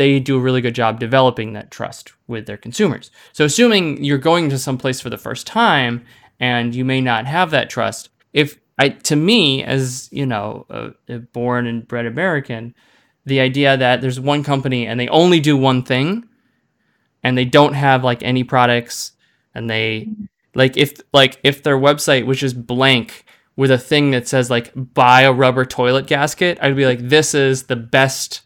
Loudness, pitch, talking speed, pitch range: -16 LUFS, 130 Hz, 190 wpm, 125-145 Hz